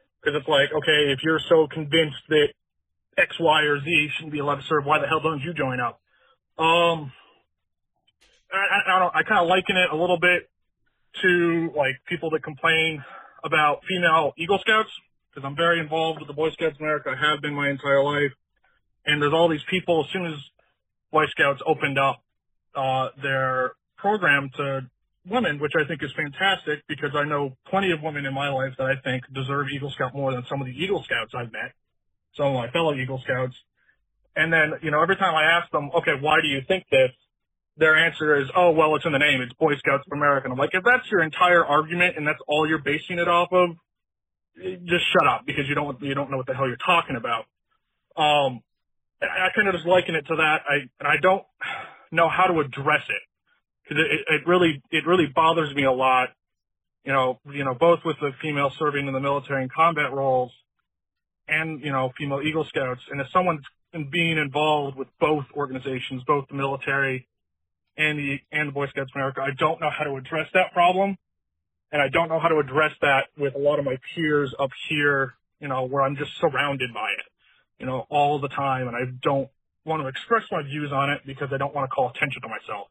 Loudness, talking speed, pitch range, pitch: -23 LUFS, 215 wpm, 135-160 Hz, 150 Hz